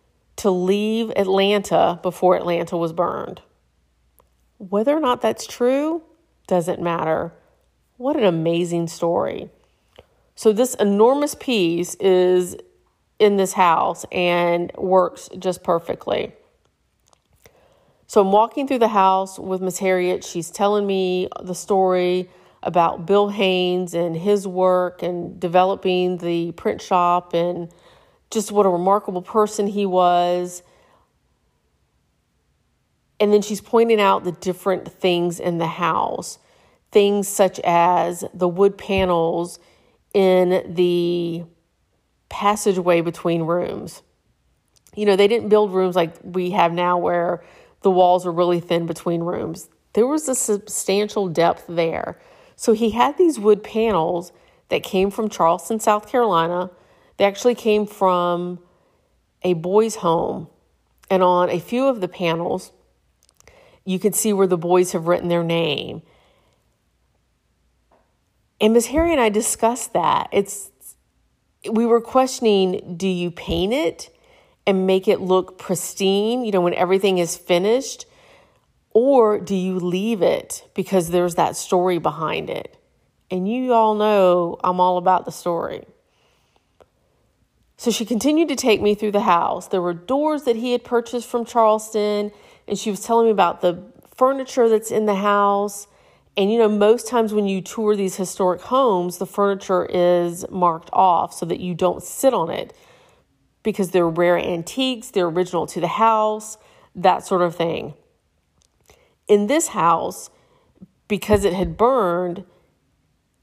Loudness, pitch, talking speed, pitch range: -20 LUFS, 190 Hz, 140 wpm, 175-215 Hz